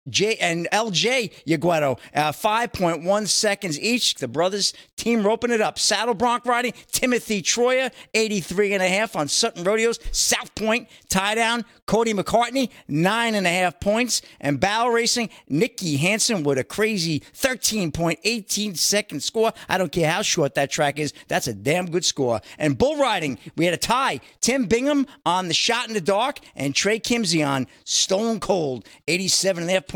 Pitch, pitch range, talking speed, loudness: 205 Hz, 170-230 Hz, 155 wpm, -22 LUFS